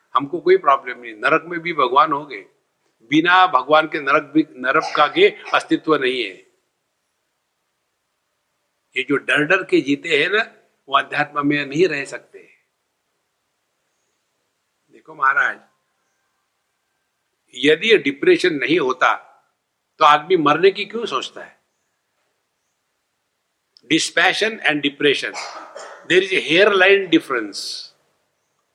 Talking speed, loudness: 115 wpm, -17 LUFS